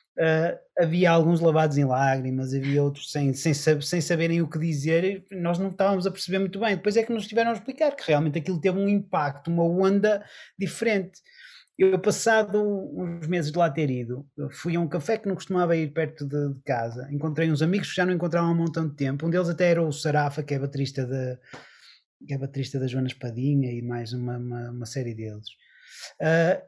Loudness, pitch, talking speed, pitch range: -25 LUFS, 165 Hz, 205 wpm, 140-190 Hz